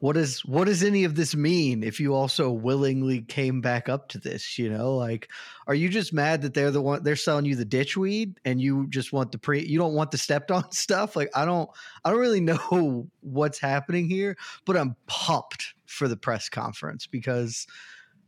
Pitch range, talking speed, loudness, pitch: 130-170 Hz, 215 wpm, -26 LUFS, 145 Hz